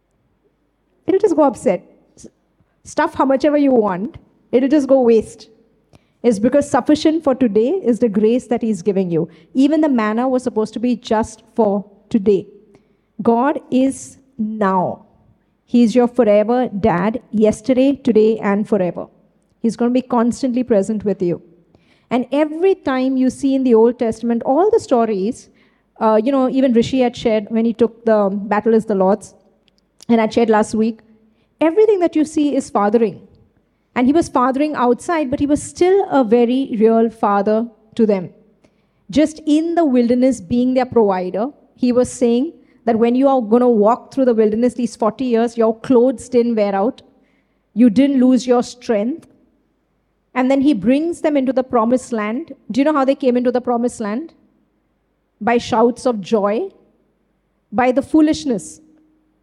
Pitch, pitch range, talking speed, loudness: 240 Hz, 220-270 Hz, 170 wpm, -16 LUFS